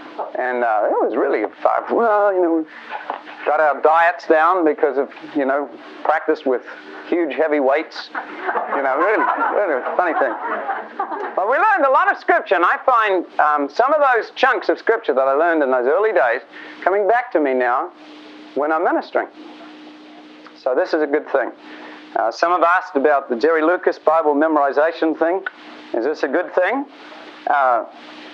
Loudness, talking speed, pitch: -18 LUFS, 180 wpm, 160 Hz